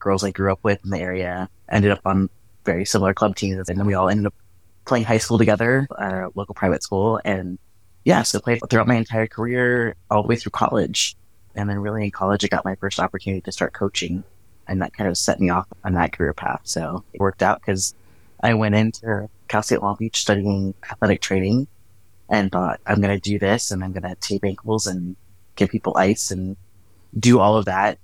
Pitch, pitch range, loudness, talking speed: 100 Hz, 95-110 Hz, -21 LUFS, 225 wpm